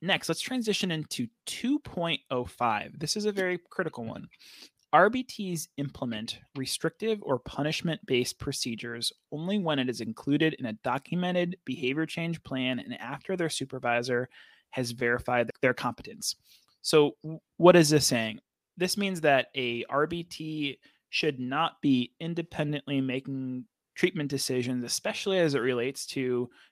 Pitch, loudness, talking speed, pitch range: 145 Hz, -29 LUFS, 135 wpm, 125-170 Hz